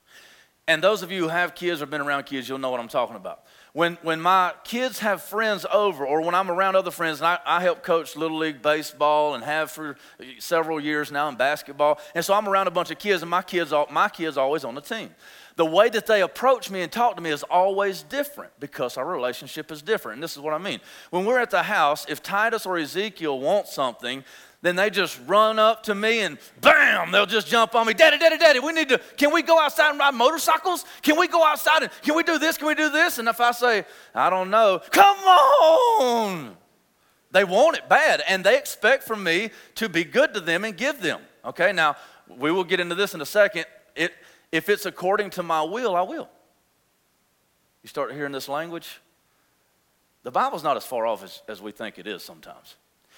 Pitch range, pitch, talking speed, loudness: 155-230 Hz, 185 Hz, 225 wpm, -22 LUFS